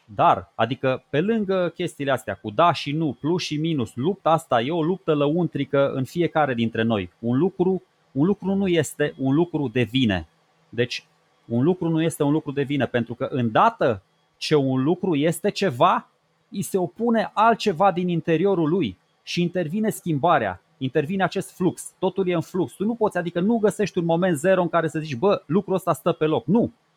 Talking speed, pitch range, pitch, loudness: 195 wpm, 140-185 Hz, 165 Hz, -23 LUFS